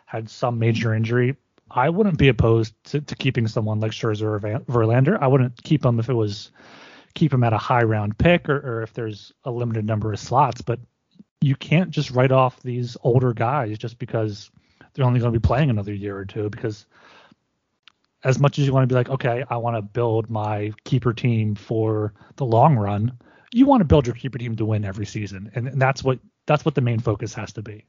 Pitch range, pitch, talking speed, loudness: 110-130 Hz, 120 Hz, 225 wpm, -22 LUFS